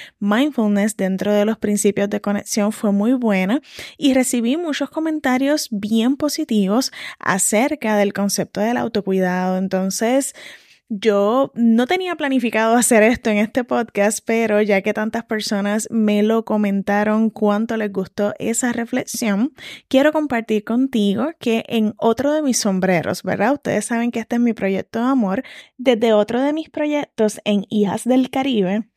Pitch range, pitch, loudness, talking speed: 205-255 Hz, 225 Hz, -19 LUFS, 150 wpm